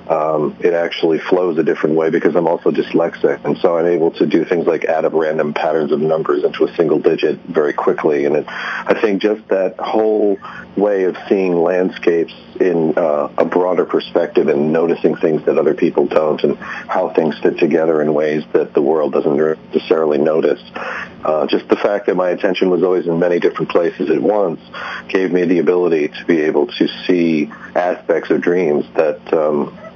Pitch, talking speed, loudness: 105 Hz, 190 wpm, -16 LUFS